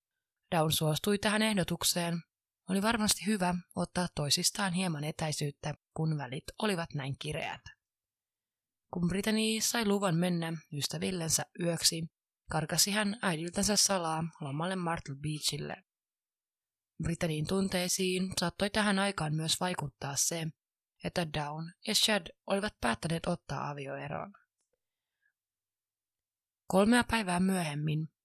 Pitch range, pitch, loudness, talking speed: 150-195 Hz, 170 Hz, -32 LUFS, 105 wpm